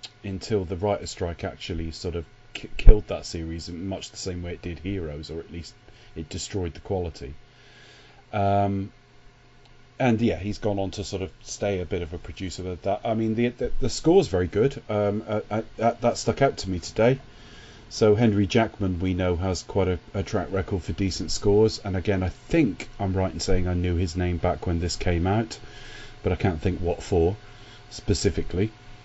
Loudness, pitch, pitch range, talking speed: -26 LUFS, 95 Hz, 90-105 Hz, 205 wpm